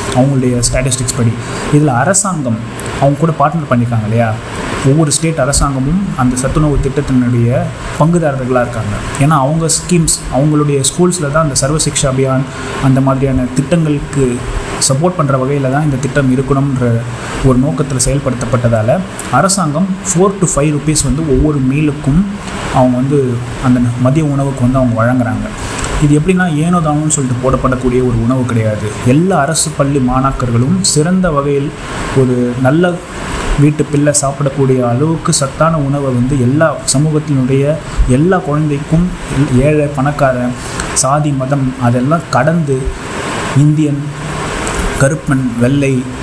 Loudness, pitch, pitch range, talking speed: -12 LUFS, 135 Hz, 125-150 Hz, 120 wpm